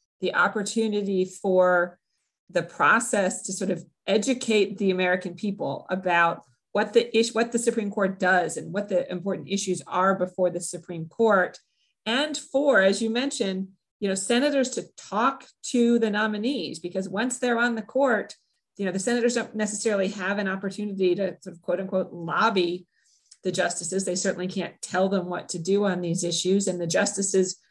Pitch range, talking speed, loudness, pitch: 180-220 Hz, 175 wpm, -25 LUFS, 195 Hz